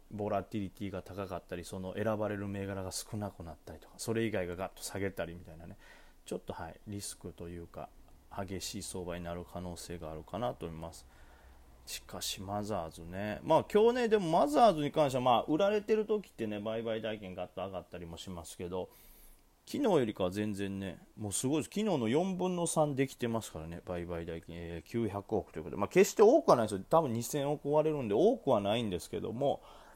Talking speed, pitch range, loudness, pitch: 420 characters per minute, 85-115 Hz, -33 LUFS, 100 Hz